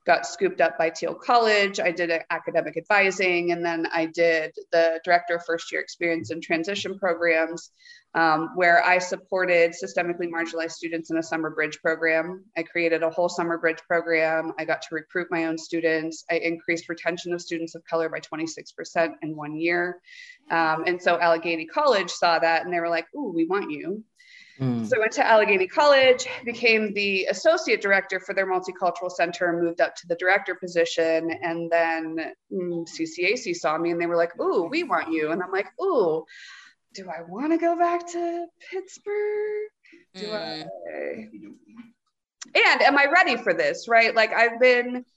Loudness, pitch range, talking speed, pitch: -23 LUFS, 165-235 Hz, 180 wpm, 175 Hz